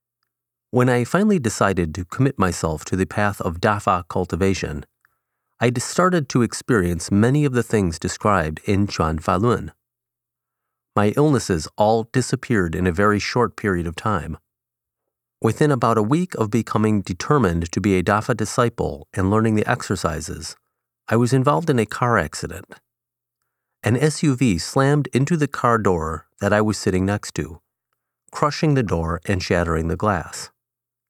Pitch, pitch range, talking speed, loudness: 105 Hz, 95-125 Hz, 150 wpm, -20 LUFS